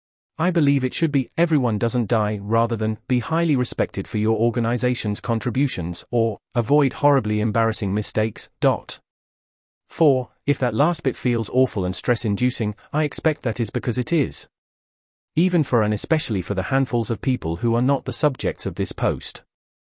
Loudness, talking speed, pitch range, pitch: -22 LUFS, 170 wpm, 105-135 Hz, 120 Hz